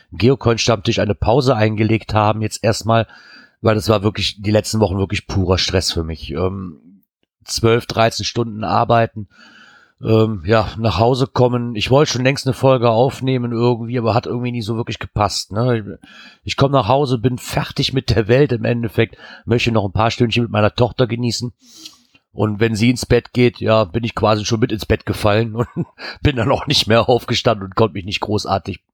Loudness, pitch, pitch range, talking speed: -17 LUFS, 115 Hz, 105-120 Hz, 195 wpm